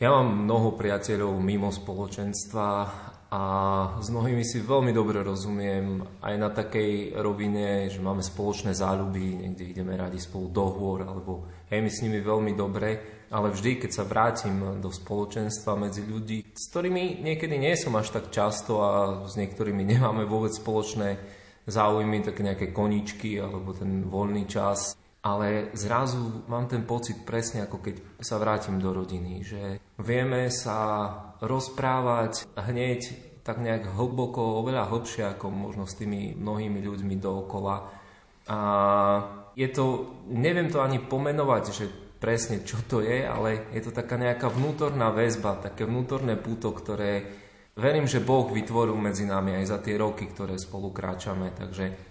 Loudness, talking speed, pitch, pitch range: -28 LUFS, 150 wpm, 105 Hz, 100-115 Hz